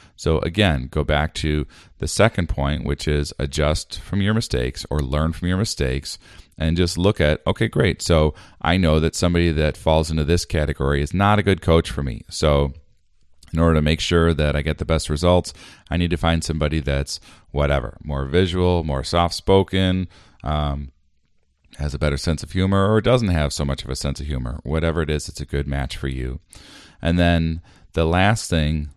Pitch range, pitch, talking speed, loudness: 75-90 Hz, 80 Hz, 200 wpm, -21 LUFS